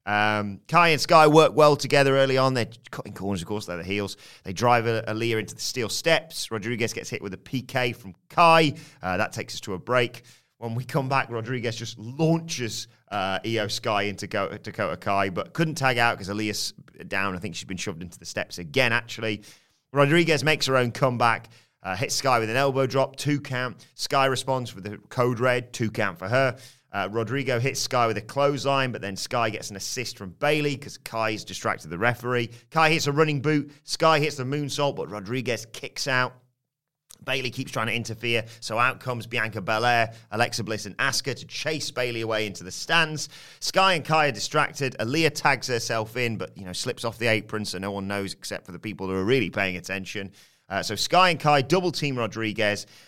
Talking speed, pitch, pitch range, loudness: 210 wpm, 120 Hz, 110-140 Hz, -25 LUFS